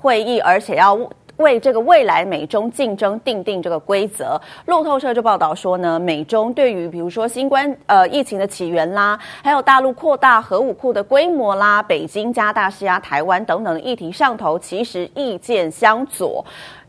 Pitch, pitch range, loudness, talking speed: 220 Hz, 195-270 Hz, -17 LUFS, 275 characters per minute